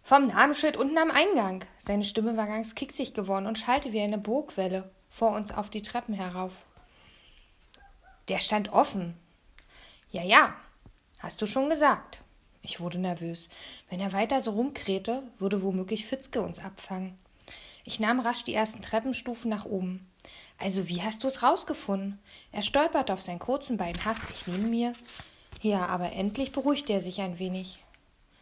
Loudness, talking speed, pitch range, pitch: -29 LUFS, 160 wpm, 190-245 Hz, 215 Hz